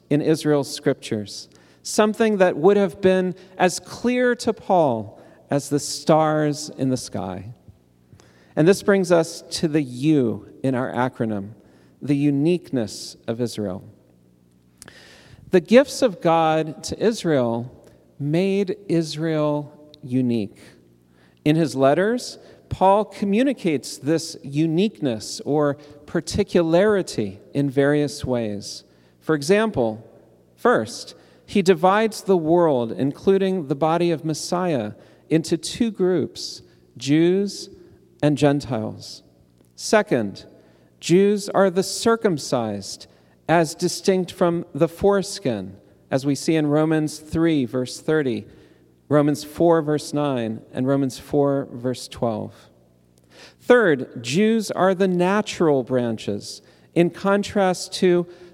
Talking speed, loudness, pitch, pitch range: 110 wpm, -21 LUFS, 150 Hz, 120-180 Hz